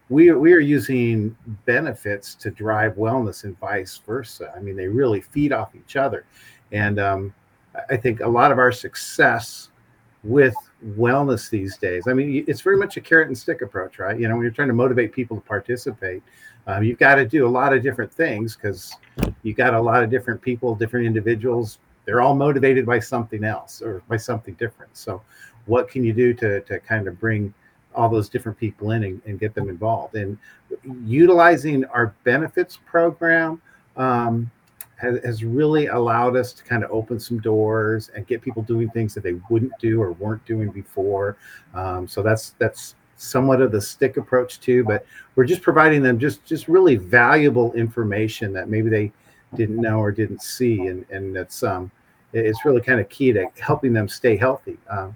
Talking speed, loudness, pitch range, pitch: 195 wpm, -20 LUFS, 110-130 Hz, 115 Hz